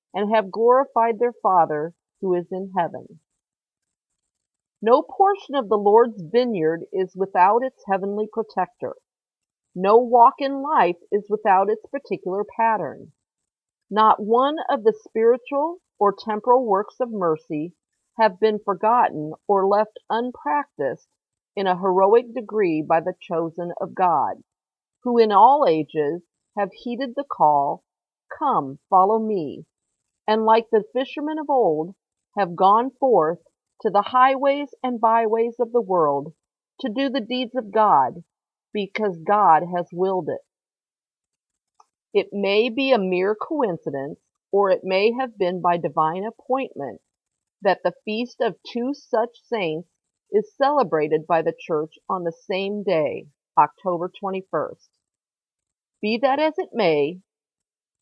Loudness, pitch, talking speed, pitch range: -21 LUFS, 215 Hz, 135 wpm, 185-245 Hz